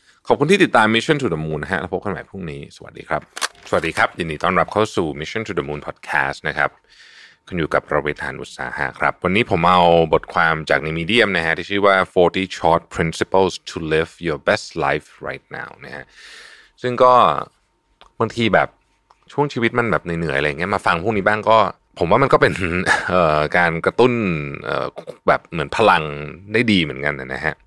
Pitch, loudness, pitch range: 90 Hz, -18 LUFS, 80-110 Hz